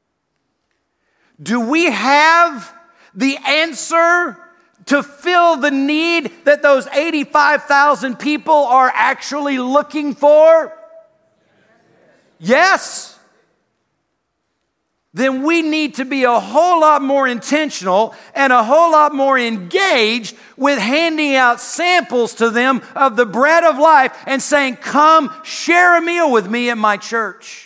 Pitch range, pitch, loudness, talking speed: 255-320 Hz, 290 Hz, -13 LUFS, 120 wpm